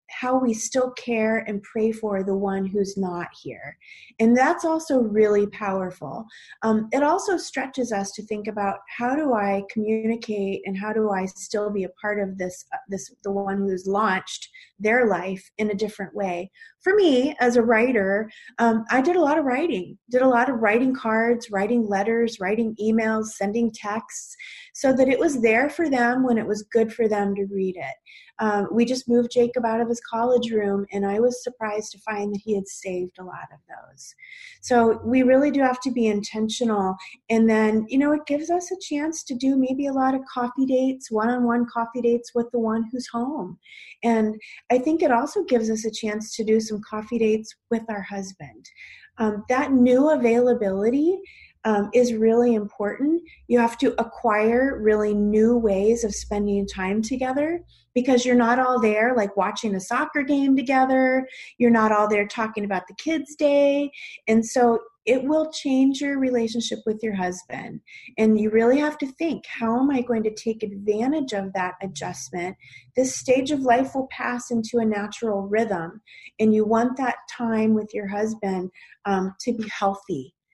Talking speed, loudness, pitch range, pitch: 190 wpm, -23 LUFS, 210-255 Hz, 225 Hz